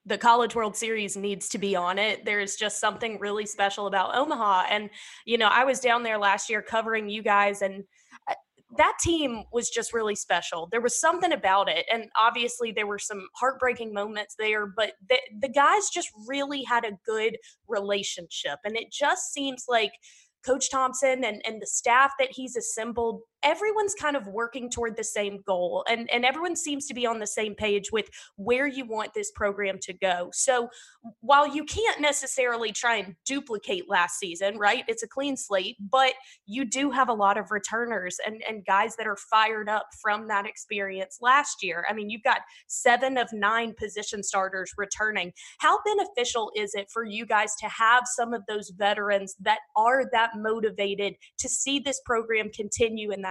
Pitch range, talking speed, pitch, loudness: 205-250 Hz, 190 wpm, 220 Hz, -26 LUFS